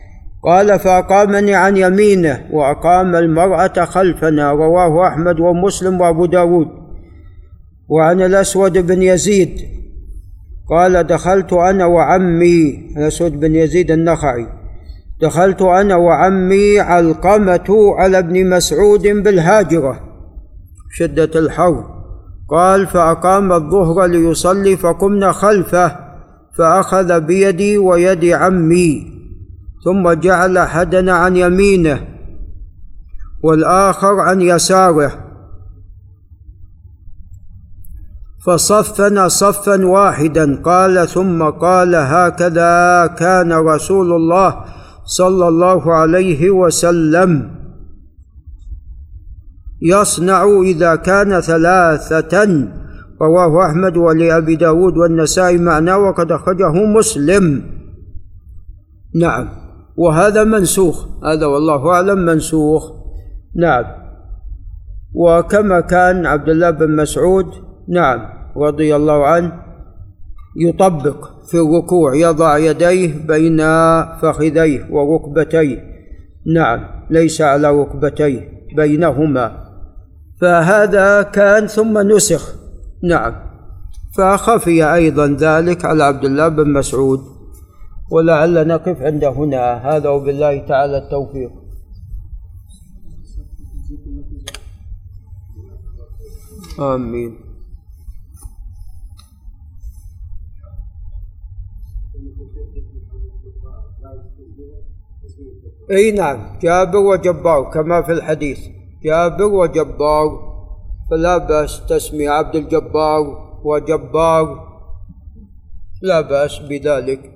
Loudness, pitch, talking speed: -12 LUFS, 155 Hz, 75 wpm